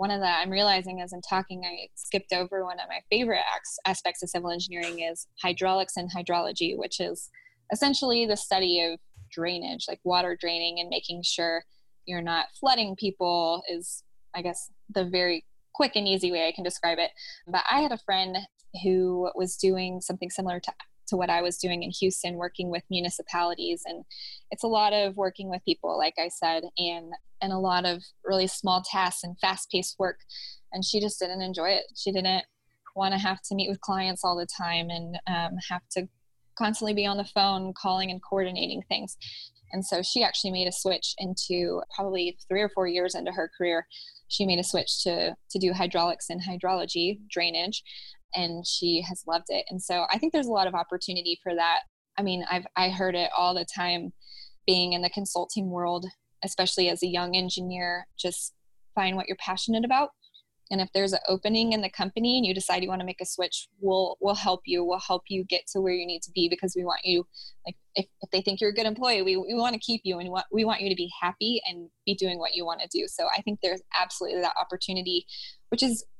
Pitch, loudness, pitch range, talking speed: 185 Hz, -28 LUFS, 175-195 Hz, 215 wpm